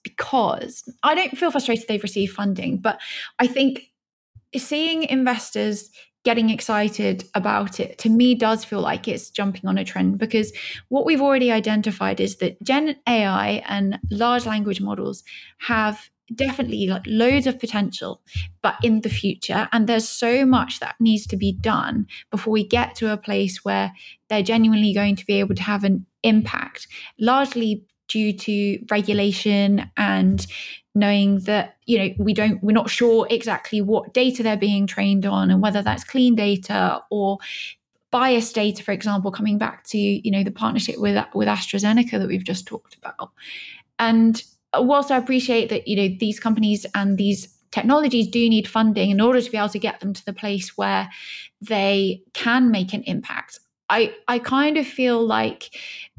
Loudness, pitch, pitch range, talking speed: -21 LUFS, 215 Hz, 200-235 Hz, 170 wpm